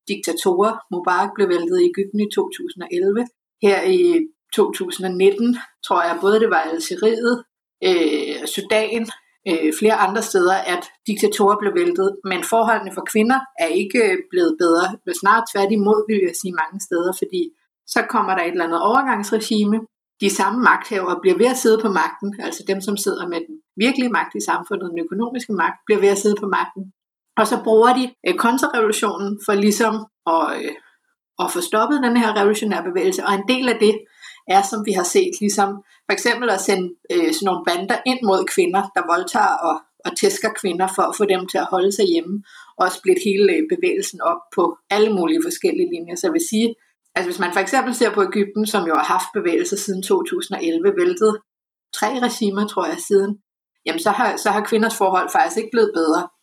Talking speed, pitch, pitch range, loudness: 190 wpm, 215 Hz, 195-255 Hz, -19 LUFS